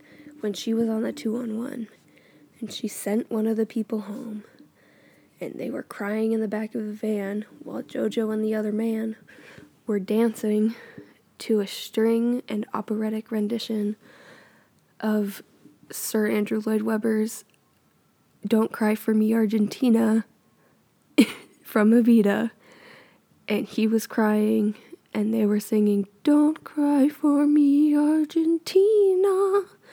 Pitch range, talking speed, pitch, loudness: 215-240 Hz, 125 wpm, 220 Hz, -24 LUFS